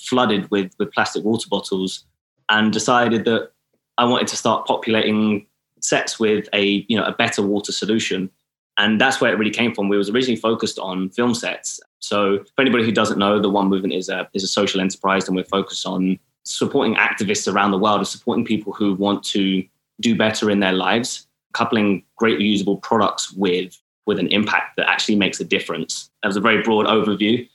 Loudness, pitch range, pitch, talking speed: -19 LUFS, 100-110 Hz, 105 Hz, 200 wpm